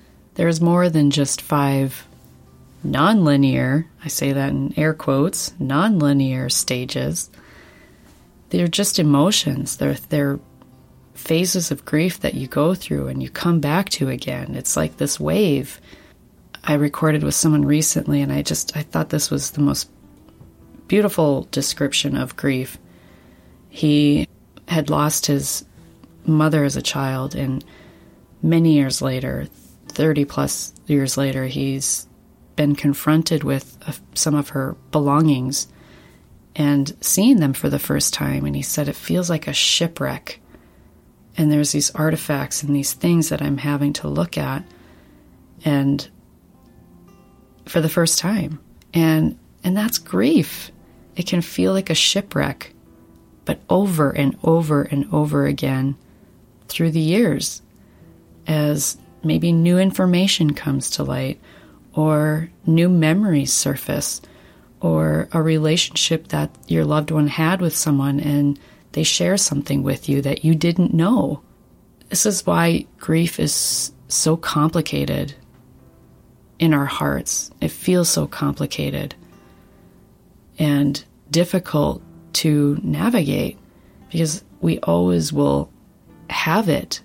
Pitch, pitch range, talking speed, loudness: 145 Hz, 135-160 Hz, 130 wpm, -19 LUFS